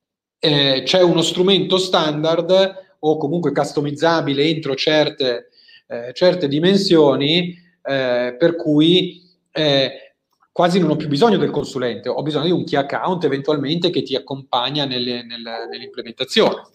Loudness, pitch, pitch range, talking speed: -17 LUFS, 155 Hz, 140-175 Hz, 135 wpm